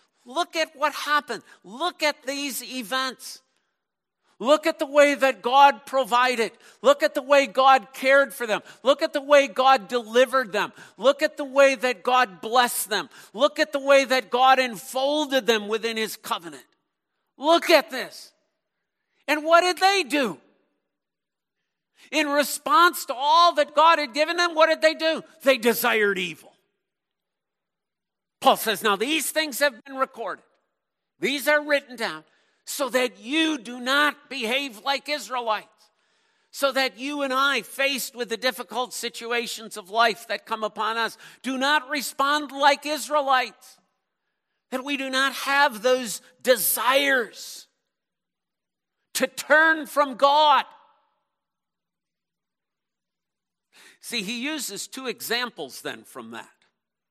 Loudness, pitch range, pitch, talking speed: -22 LUFS, 245-295 Hz, 270 Hz, 140 wpm